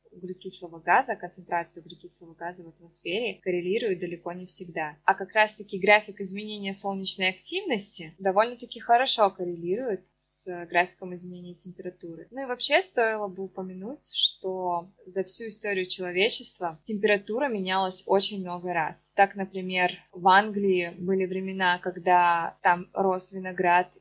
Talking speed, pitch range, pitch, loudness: 130 wpm, 180-200 Hz, 185 Hz, -25 LUFS